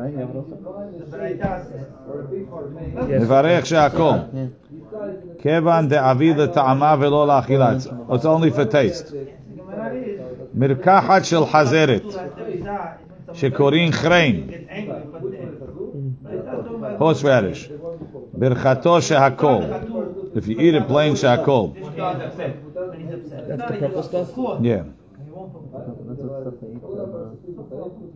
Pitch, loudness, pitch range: 150 Hz, -19 LUFS, 135-165 Hz